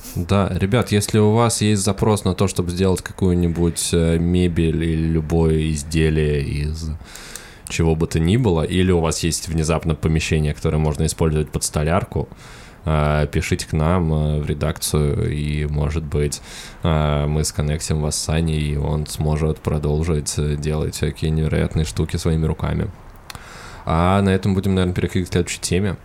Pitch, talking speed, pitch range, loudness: 80 Hz, 150 wpm, 75-90 Hz, -20 LUFS